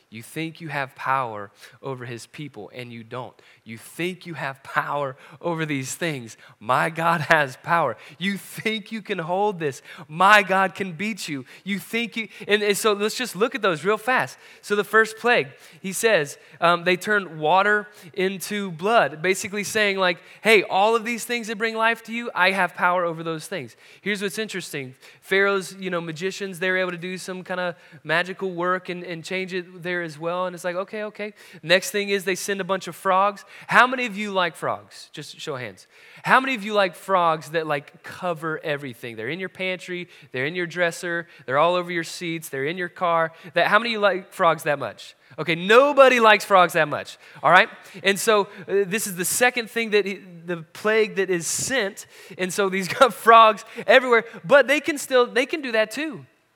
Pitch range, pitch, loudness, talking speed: 165-210 Hz, 185 Hz, -22 LUFS, 215 wpm